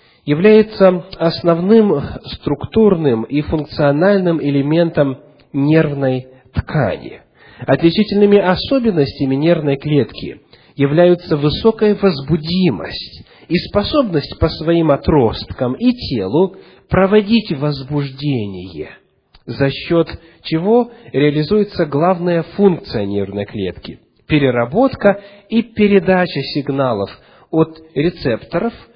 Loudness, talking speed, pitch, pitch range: -15 LUFS, 80 wpm, 160 Hz, 140-195 Hz